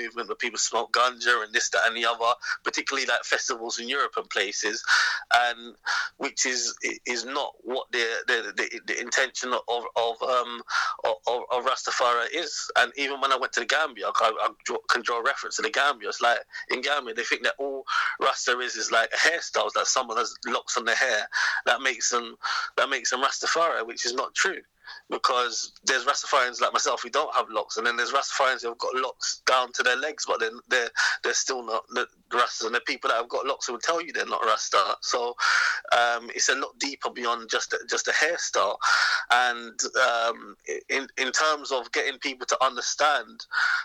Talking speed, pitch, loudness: 205 wpm, 130 Hz, -25 LUFS